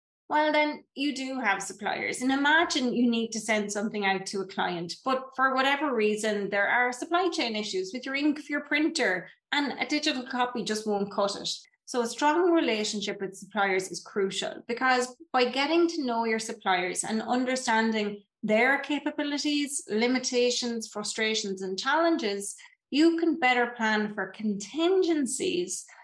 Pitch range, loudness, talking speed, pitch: 210-295 Hz, -27 LUFS, 160 wpm, 245 Hz